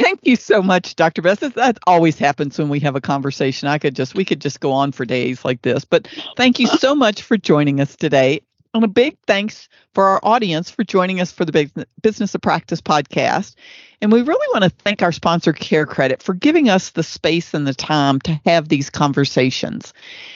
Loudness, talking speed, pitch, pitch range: -17 LUFS, 215 wpm, 170 Hz, 145-210 Hz